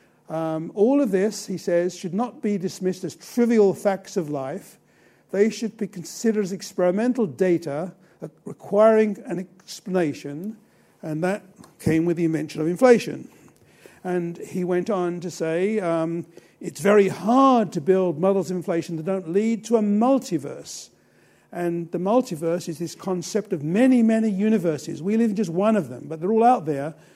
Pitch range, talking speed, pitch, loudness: 170-210 Hz, 170 wpm, 185 Hz, -23 LUFS